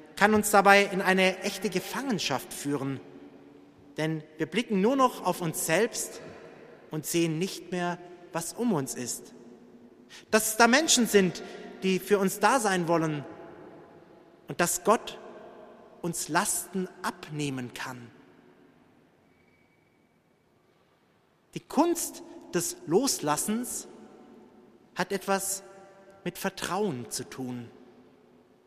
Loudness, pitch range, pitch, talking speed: -27 LUFS, 155-210 Hz, 185 Hz, 110 wpm